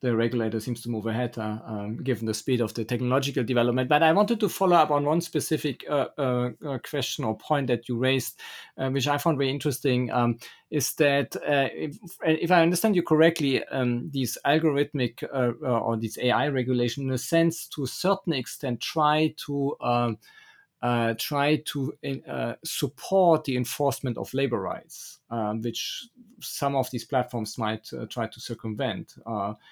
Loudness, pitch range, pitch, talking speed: -26 LUFS, 120-150 Hz, 135 Hz, 180 wpm